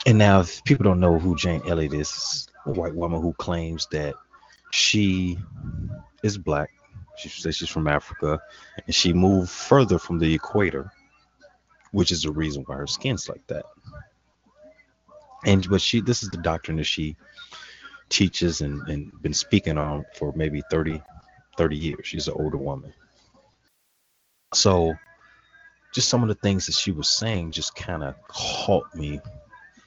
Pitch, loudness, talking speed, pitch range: 85 Hz, -24 LUFS, 160 wpm, 80-105 Hz